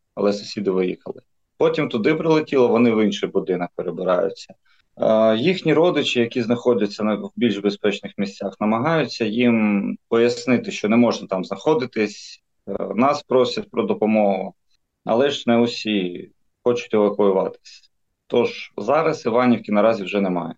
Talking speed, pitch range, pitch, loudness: 125 wpm, 100-120 Hz, 110 Hz, -20 LUFS